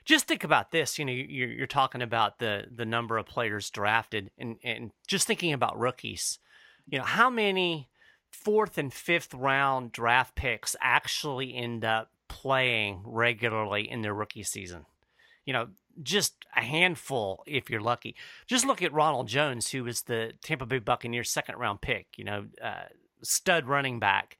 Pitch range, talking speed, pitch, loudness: 115-155 Hz, 165 wpm, 125 Hz, -29 LUFS